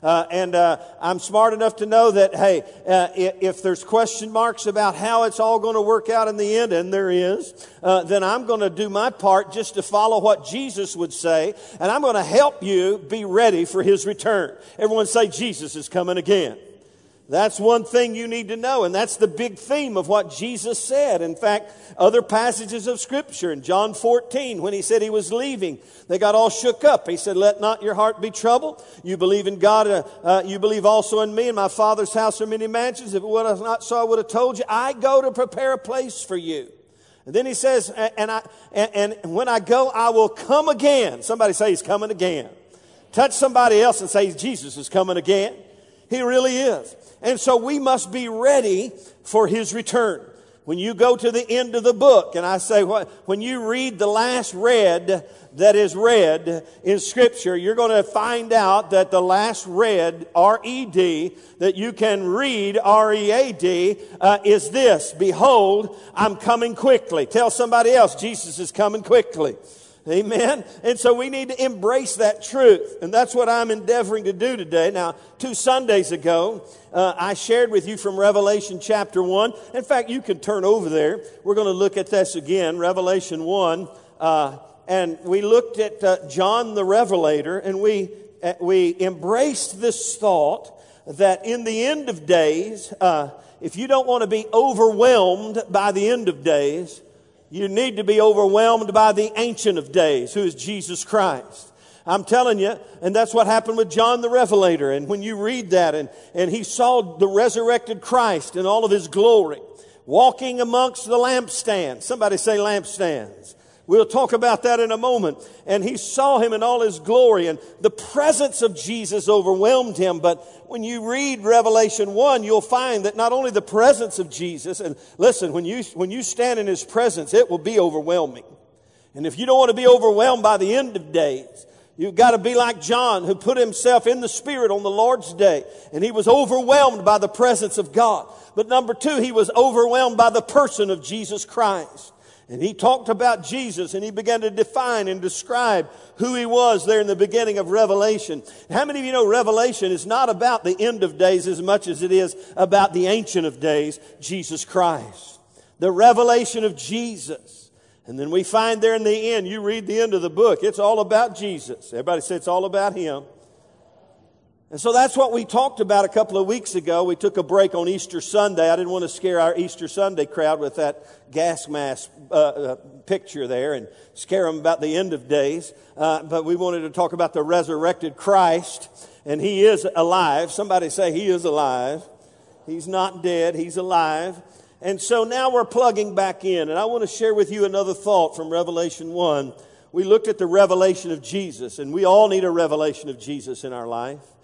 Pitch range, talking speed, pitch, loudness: 185-235 Hz, 200 wpm, 210 Hz, -19 LUFS